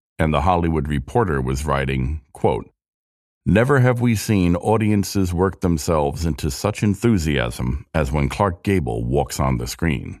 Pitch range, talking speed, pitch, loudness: 70-95 Hz, 145 wpm, 80 Hz, -20 LUFS